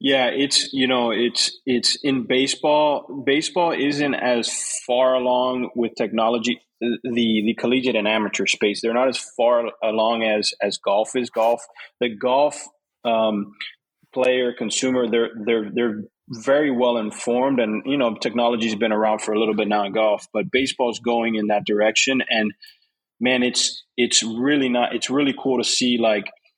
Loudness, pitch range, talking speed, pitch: -20 LUFS, 110-130 Hz, 165 wpm, 120 Hz